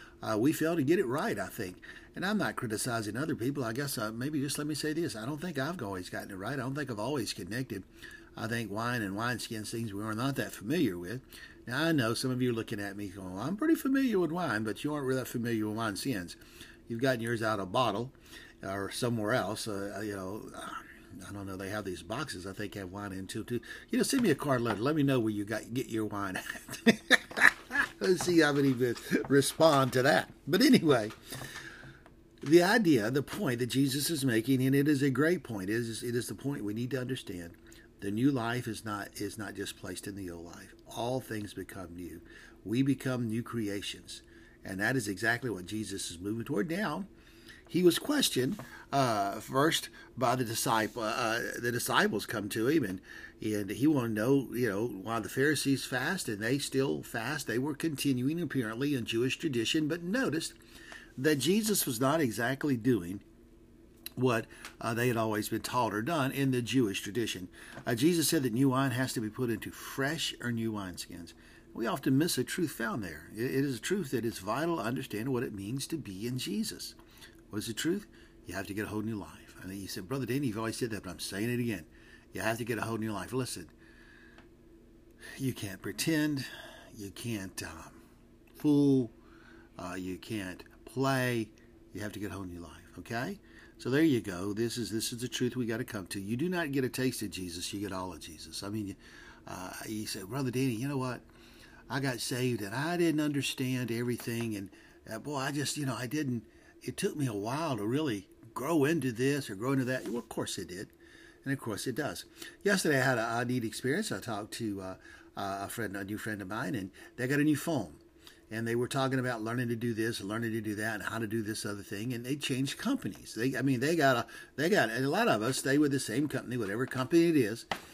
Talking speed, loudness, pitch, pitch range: 225 wpm, -32 LUFS, 115 Hz, 105-135 Hz